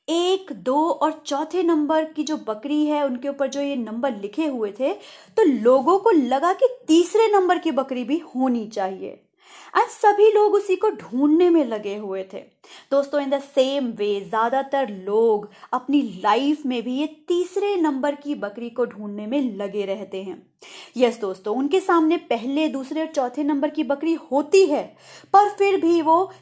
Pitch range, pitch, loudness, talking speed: 245-330 Hz, 285 Hz, -21 LUFS, 175 wpm